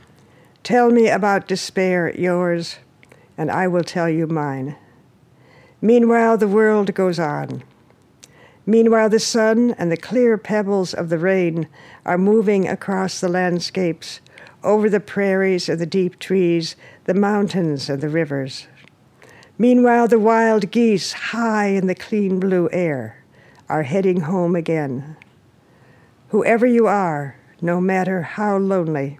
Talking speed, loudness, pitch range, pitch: 130 wpm, -18 LUFS, 165-210 Hz, 185 Hz